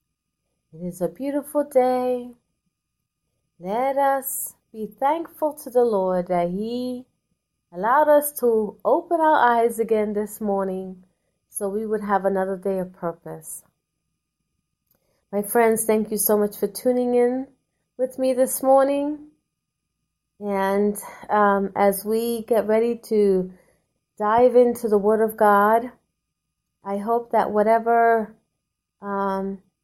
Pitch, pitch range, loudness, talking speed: 220 Hz, 200-250 Hz, -21 LUFS, 125 wpm